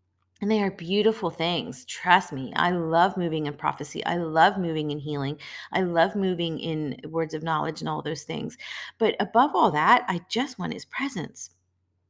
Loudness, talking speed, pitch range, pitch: -25 LUFS, 185 wpm, 150-180 Hz, 165 Hz